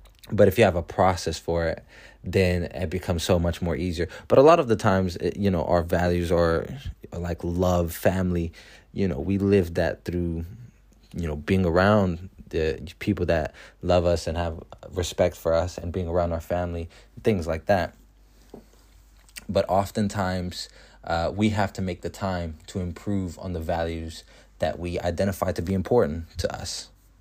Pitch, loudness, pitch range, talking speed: 90 Hz, -25 LUFS, 85-95 Hz, 175 wpm